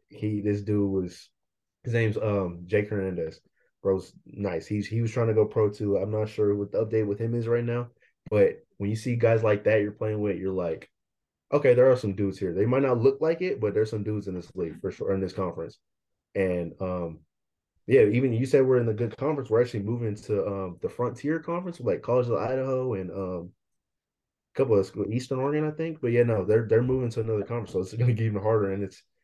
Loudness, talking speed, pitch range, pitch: -27 LUFS, 240 wpm, 100-120 Hz, 110 Hz